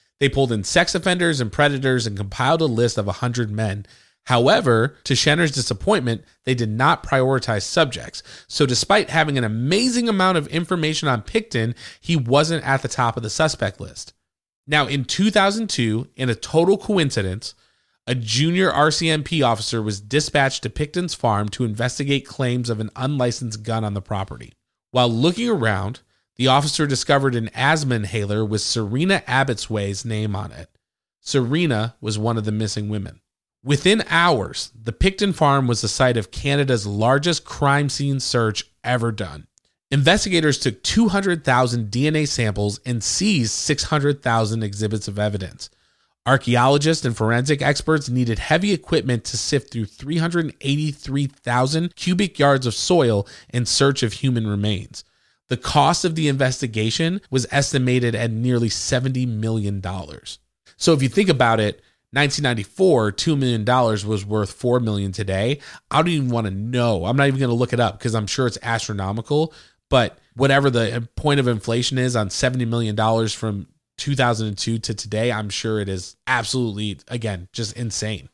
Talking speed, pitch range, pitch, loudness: 155 wpm, 110-145 Hz, 125 Hz, -20 LUFS